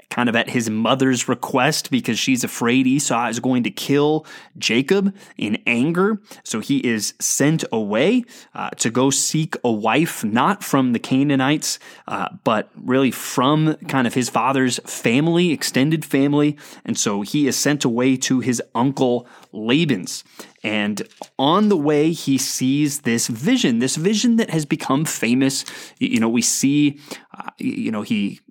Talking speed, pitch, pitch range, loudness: 160 wpm, 140 Hz, 125-165 Hz, -19 LUFS